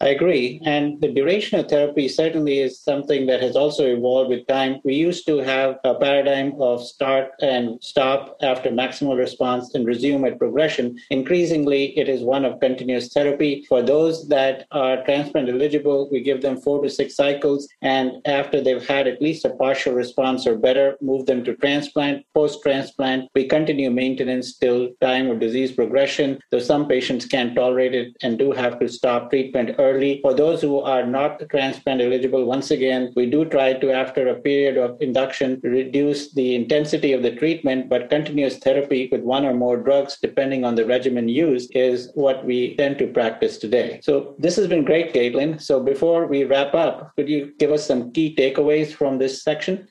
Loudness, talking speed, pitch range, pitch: -20 LUFS, 185 wpm, 130-145 Hz, 135 Hz